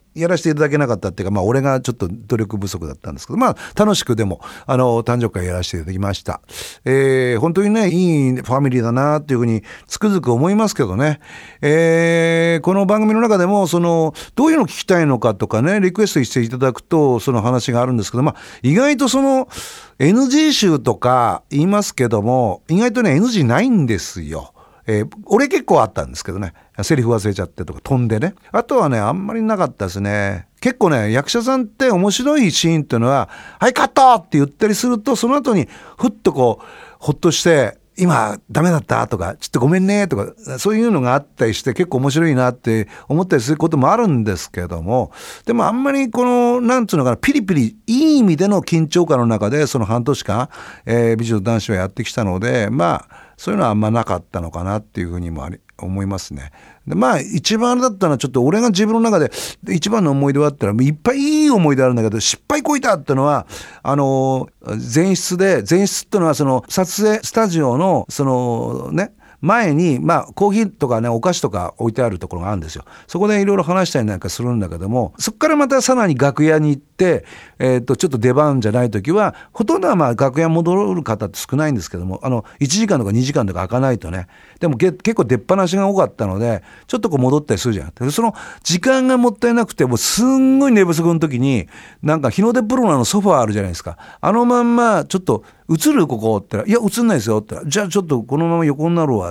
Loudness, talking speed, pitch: -16 LUFS, 455 characters per minute, 145 Hz